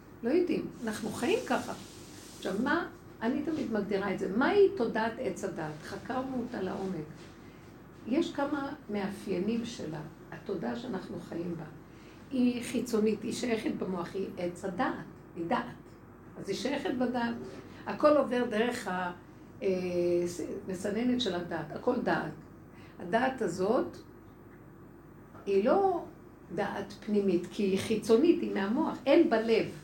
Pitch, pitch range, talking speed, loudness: 215 Hz, 185-250 Hz, 125 wpm, -32 LUFS